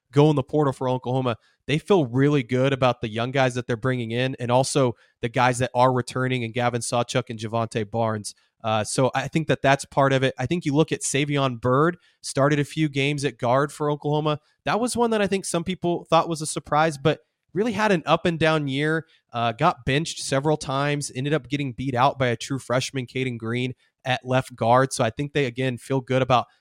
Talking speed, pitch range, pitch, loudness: 230 wpm, 125-150 Hz, 135 Hz, -23 LUFS